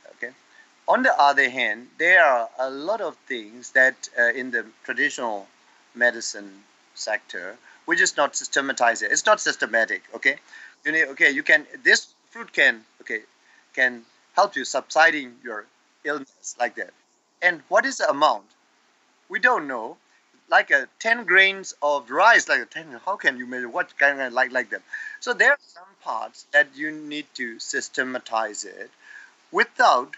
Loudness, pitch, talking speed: -21 LUFS, 155 Hz, 165 wpm